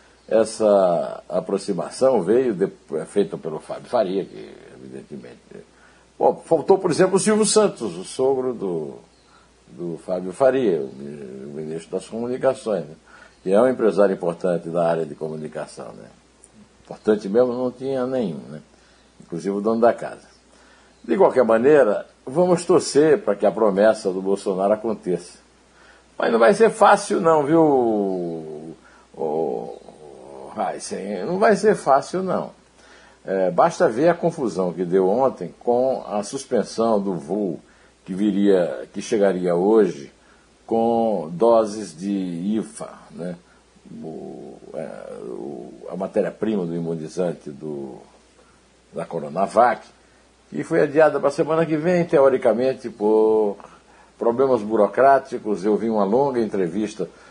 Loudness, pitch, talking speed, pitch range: -20 LUFS, 110 Hz, 130 wpm, 95-135 Hz